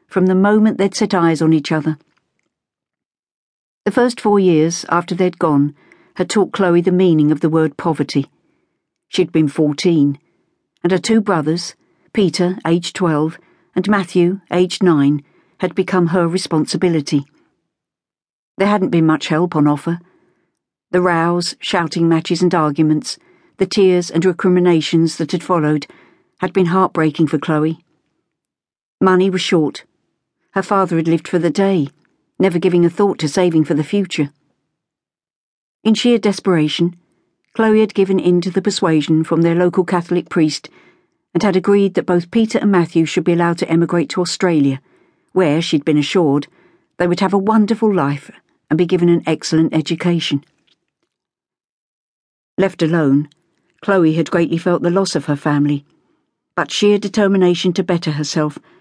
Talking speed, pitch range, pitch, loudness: 155 wpm, 160-190 Hz, 175 Hz, -16 LUFS